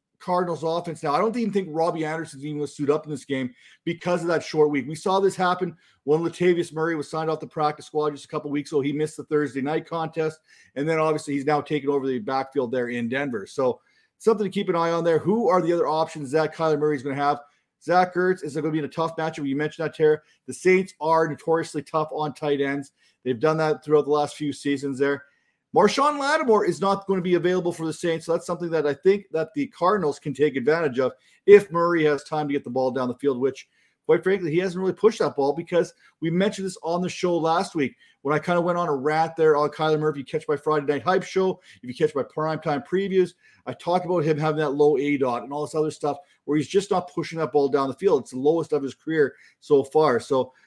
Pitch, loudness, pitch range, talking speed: 155 Hz, -24 LUFS, 145-175 Hz, 260 wpm